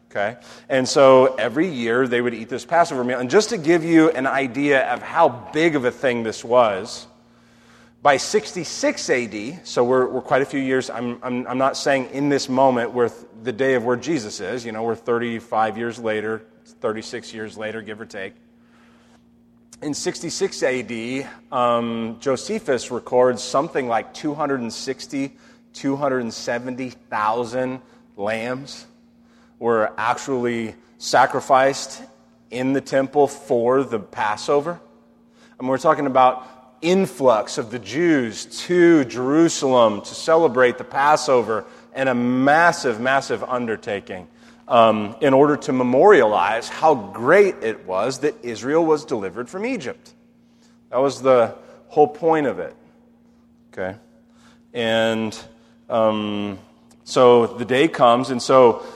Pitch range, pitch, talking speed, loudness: 115-145 Hz, 130 Hz, 135 wpm, -20 LUFS